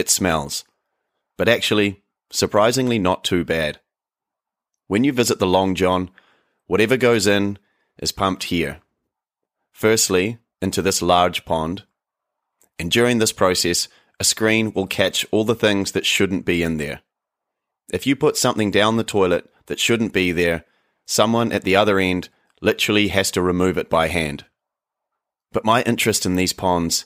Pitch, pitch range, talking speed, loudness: 95 Hz, 90-110 Hz, 155 wpm, -19 LUFS